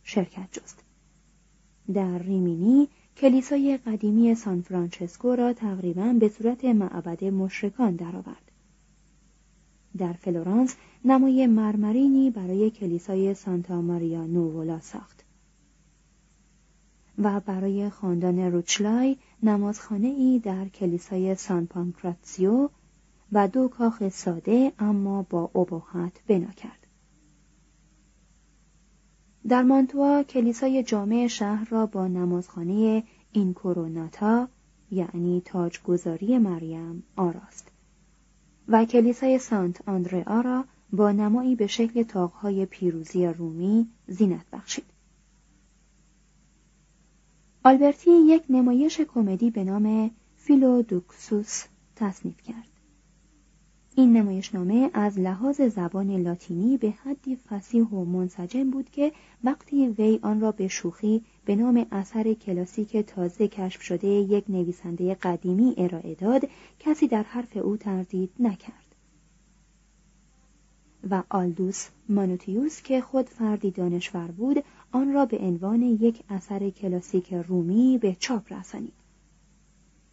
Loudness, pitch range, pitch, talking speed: -25 LUFS, 180-230 Hz, 195 Hz, 105 wpm